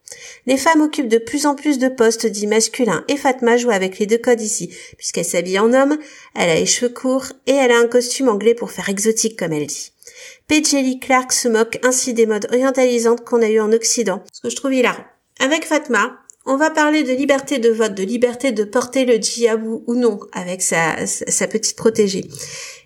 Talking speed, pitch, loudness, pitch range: 210 wpm, 240 Hz, -17 LUFS, 225-270 Hz